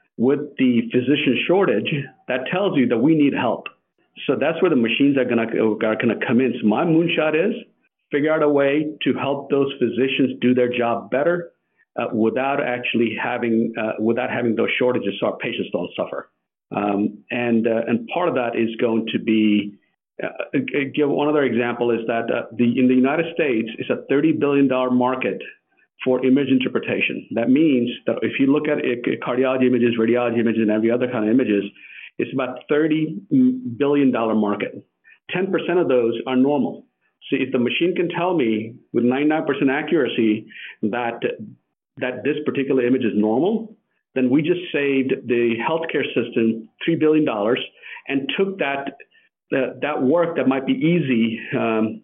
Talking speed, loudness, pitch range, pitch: 170 wpm, -20 LUFS, 115-145 Hz, 130 Hz